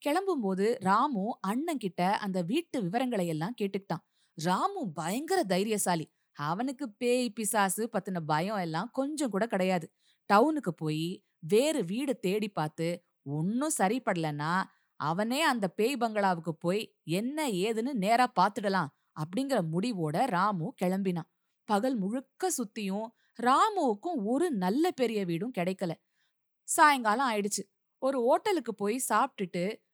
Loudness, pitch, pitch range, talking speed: -30 LUFS, 210 Hz, 180-255 Hz, 115 wpm